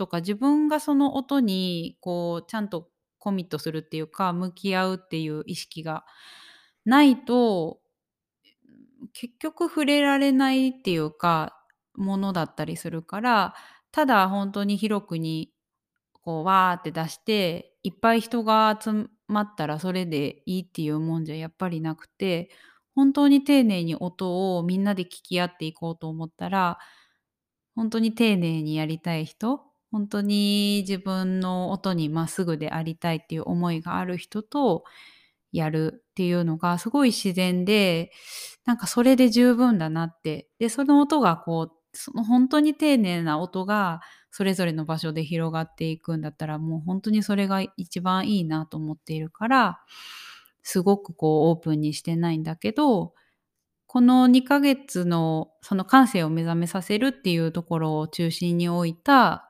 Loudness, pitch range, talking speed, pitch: -24 LUFS, 165-225 Hz, 310 characters per minute, 185 Hz